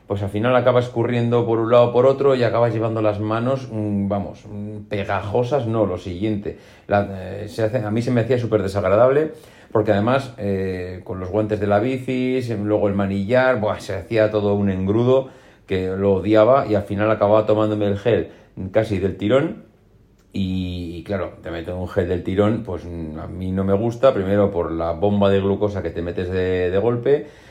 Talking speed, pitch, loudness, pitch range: 195 wpm, 105 Hz, -20 LUFS, 100-115 Hz